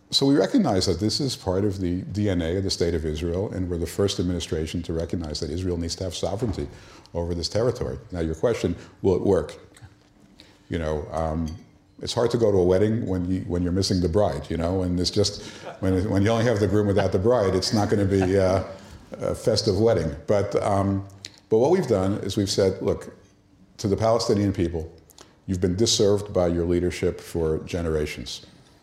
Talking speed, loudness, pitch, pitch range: 205 wpm, -24 LUFS, 95 Hz, 85-100 Hz